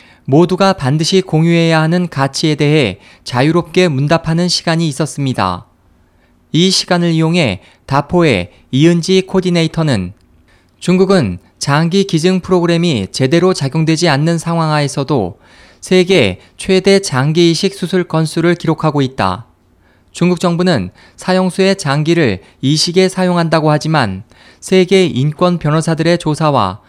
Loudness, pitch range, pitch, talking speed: -13 LUFS, 125-175 Hz, 160 Hz, 295 characters per minute